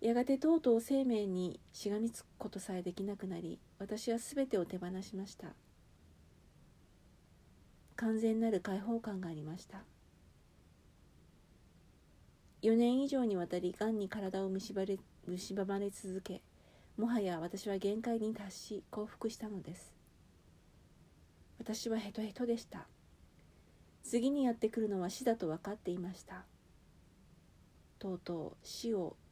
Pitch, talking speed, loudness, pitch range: 200 Hz, 250 characters per minute, -38 LUFS, 180-225 Hz